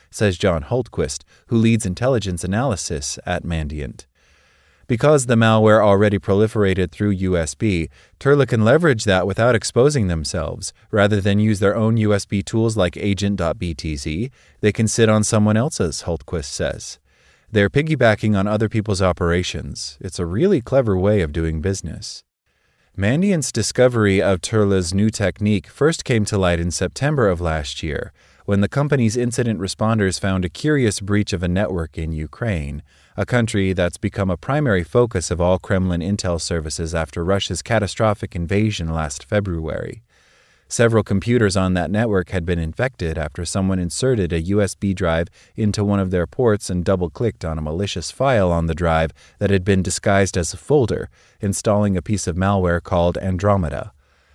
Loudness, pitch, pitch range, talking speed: -19 LUFS, 100 Hz, 85-110 Hz, 160 wpm